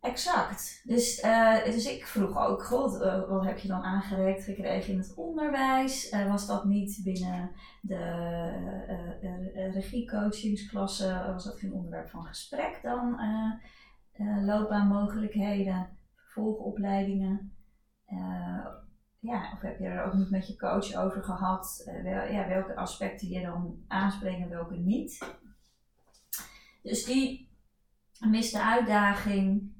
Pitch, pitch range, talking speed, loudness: 200 Hz, 190-220 Hz, 130 wpm, -31 LUFS